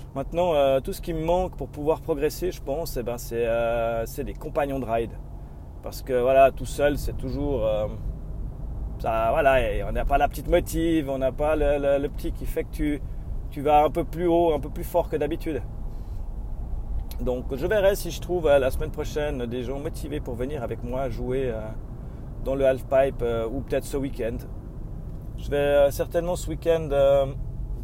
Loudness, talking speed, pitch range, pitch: -25 LUFS, 205 wpm, 120-150 Hz, 135 Hz